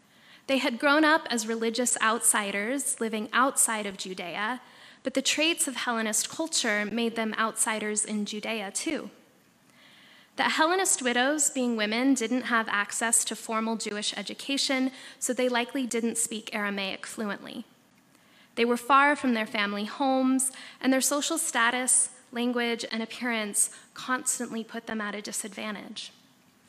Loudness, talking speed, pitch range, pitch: -27 LUFS, 140 wpm, 220-265 Hz, 235 Hz